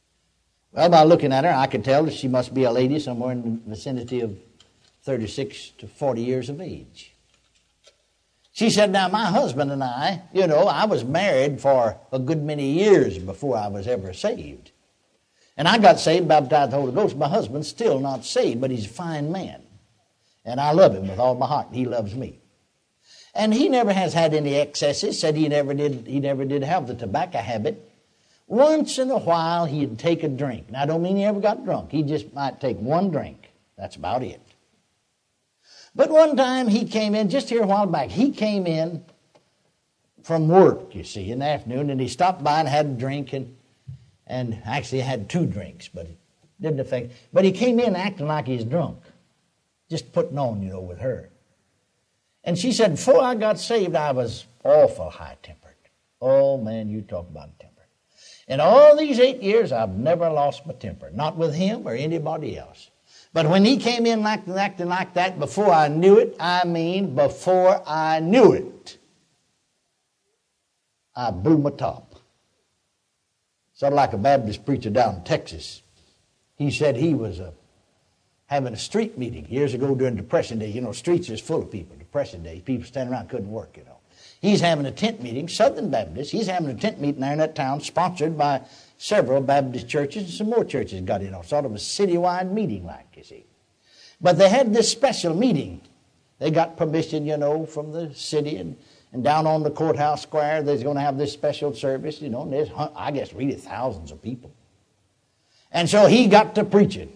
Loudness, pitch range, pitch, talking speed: -21 LUFS, 125-180 Hz, 145 Hz, 195 wpm